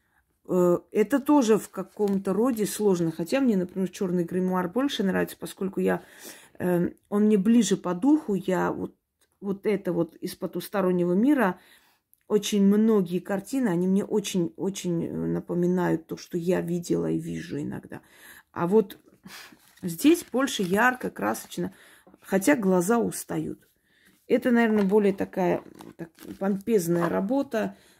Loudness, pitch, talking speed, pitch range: -26 LUFS, 195 Hz, 120 wpm, 175-215 Hz